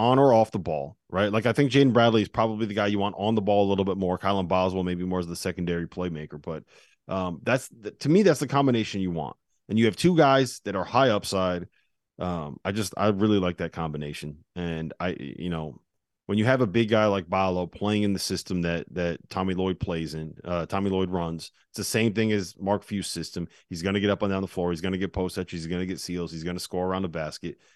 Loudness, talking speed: -26 LUFS, 260 wpm